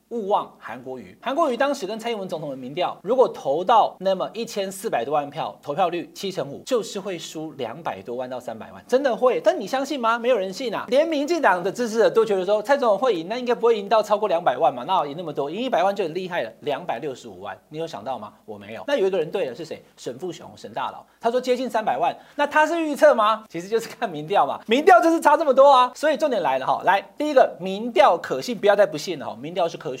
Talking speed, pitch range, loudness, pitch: 385 characters per minute, 190-280 Hz, -22 LUFS, 230 Hz